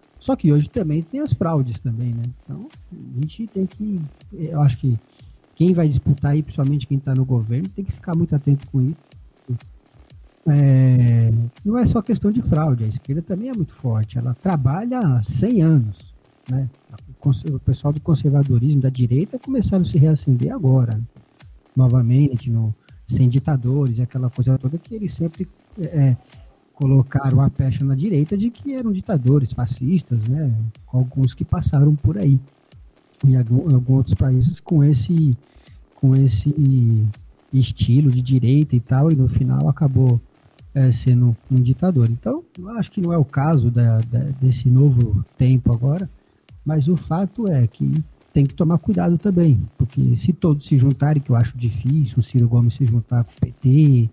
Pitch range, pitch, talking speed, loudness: 125-155 Hz, 135 Hz, 170 wpm, -19 LUFS